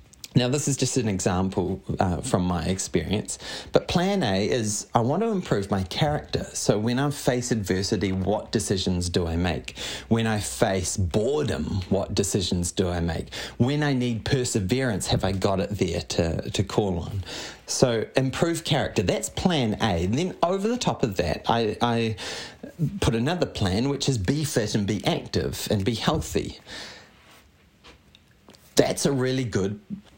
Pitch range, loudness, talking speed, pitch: 95-130 Hz, -25 LUFS, 165 wpm, 110 Hz